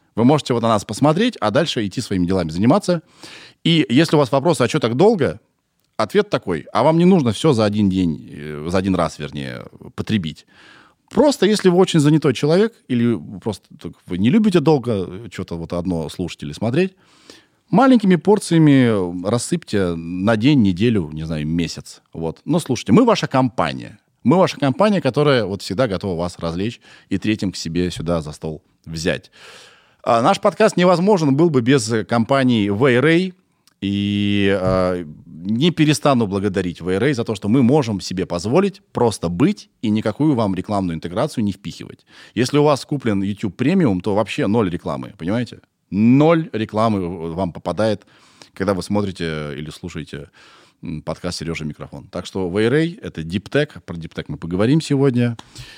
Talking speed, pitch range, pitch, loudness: 160 wpm, 90-150 Hz, 110 Hz, -18 LUFS